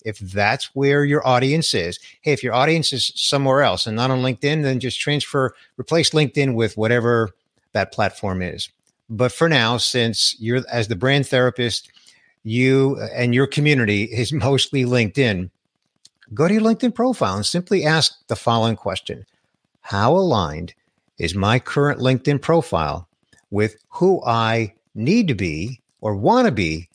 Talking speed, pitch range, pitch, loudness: 160 wpm, 110-145 Hz, 125 Hz, -19 LUFS